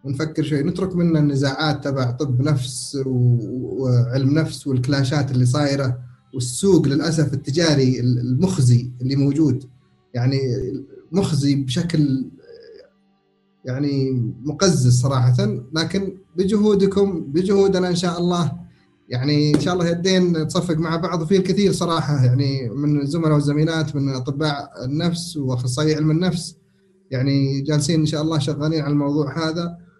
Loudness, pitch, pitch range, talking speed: -20 LUFS, 150 Hz, 135-170 Hz, 120 wpm